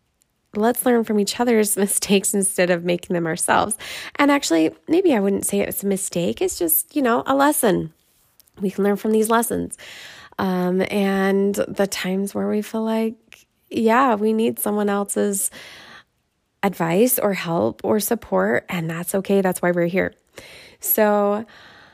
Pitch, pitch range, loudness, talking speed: 200 Hz, 190-225 Hz, -20 LUFS, 160 wpm